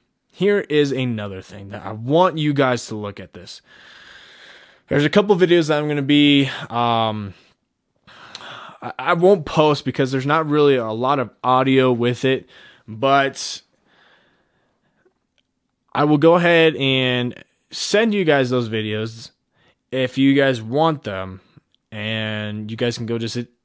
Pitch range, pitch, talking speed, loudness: 115-150 Hz, 130 Hz, 150 wpm, -18 LUFS